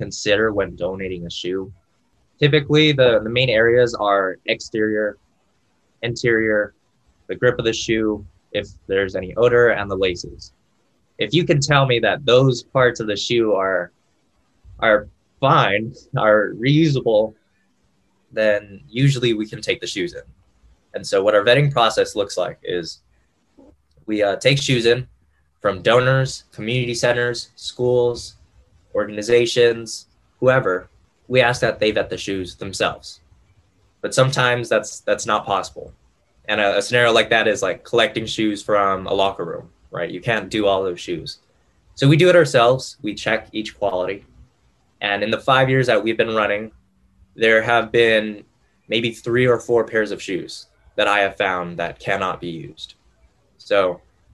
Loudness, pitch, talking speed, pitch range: -19 LUFS, 110 Hz, 155 wpm, 100-125 Hz